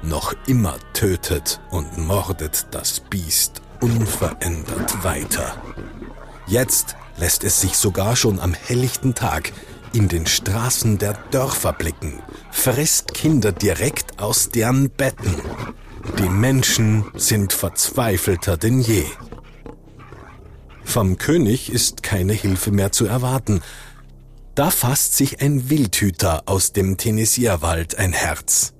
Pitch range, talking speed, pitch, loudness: 95-120 Hz, 115 wpm, 105 Hz, -19 LUFS